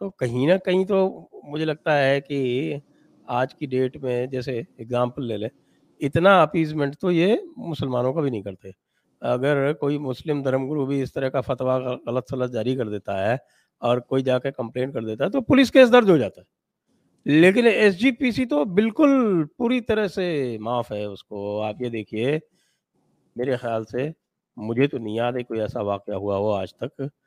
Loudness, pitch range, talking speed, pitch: -22 LUFS, 120-160 Hz, 185 wpm, 135 Hz